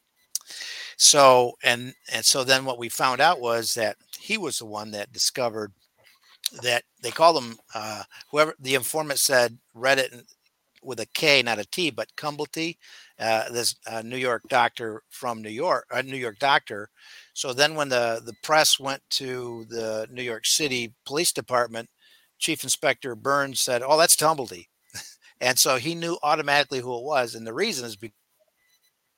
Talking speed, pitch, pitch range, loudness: 175 wpm, 125 Hz, 115-145 Hz, -23 LUFS